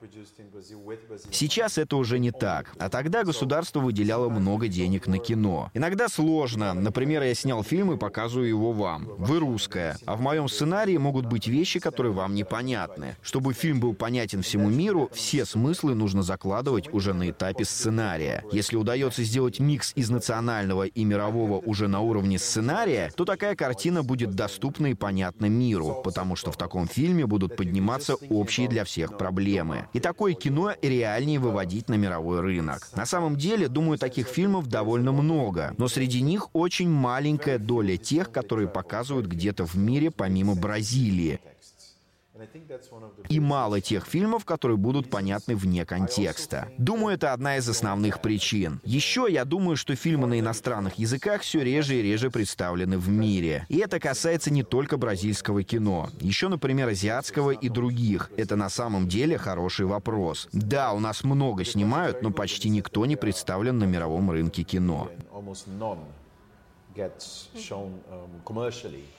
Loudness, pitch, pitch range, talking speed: -26 LUFS, 115 Hz, 100-135 Hz, 150 wpm